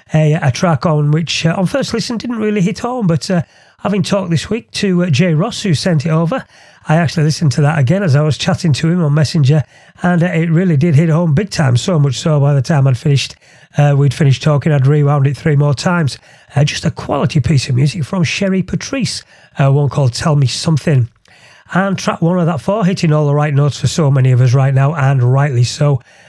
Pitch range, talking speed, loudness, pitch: 140-175 Hz, 240 wpm, -14 LUFS, 155 Hz